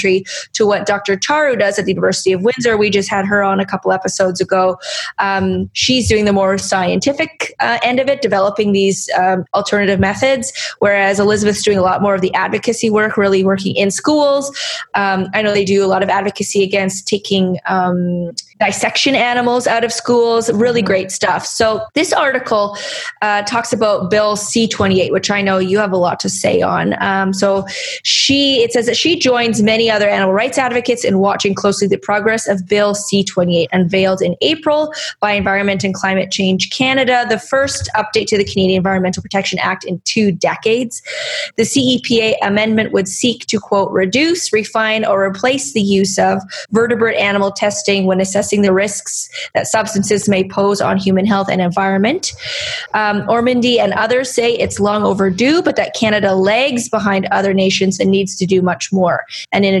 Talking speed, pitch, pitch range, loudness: 185 wpm, 205 Hz, 195-230 Hz, -14 LUFS